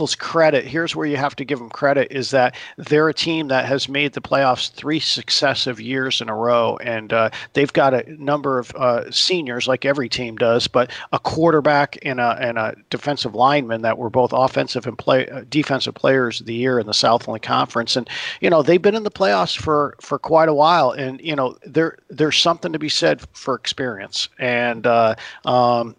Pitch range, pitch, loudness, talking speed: 120-150 Hz, 130 Hz, -19 LUFS, 210 wpm